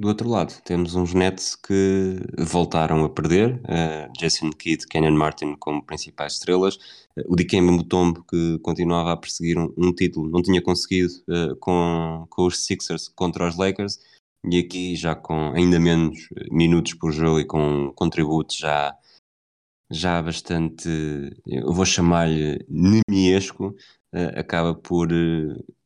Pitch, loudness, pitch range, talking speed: 85 Hz, -22 LUFS, 80-90 Hz, 145 wpm